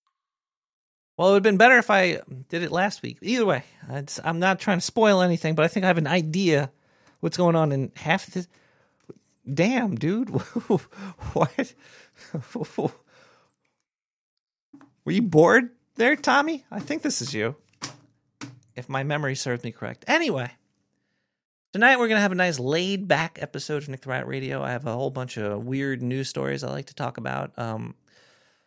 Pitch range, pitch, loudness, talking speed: 135-220 Hz, 170 Hz, -24 LUFS, 175 wpm